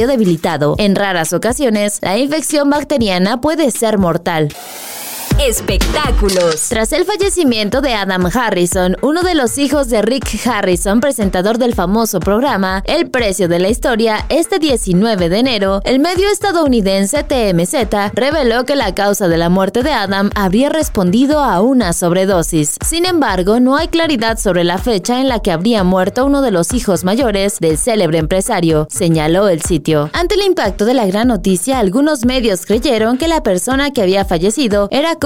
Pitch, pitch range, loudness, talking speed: 215 Hz, 185-275 Hz, -13 LUFS, 165 wpm